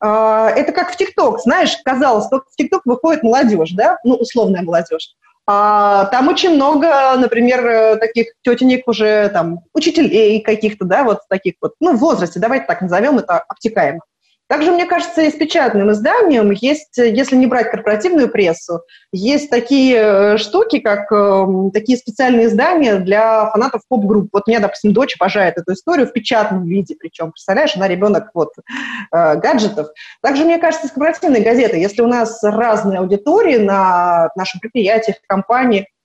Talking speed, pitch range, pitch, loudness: 160 wpm, 200-270 Hz, 225 Hz, -14 LUFS